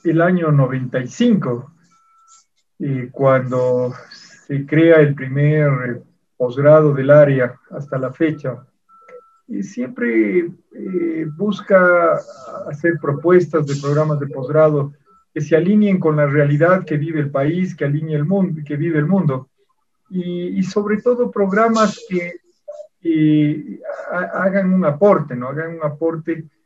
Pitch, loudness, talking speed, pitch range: 160 Hz, -17 LUFS, 130 wpm, 145-190 Hz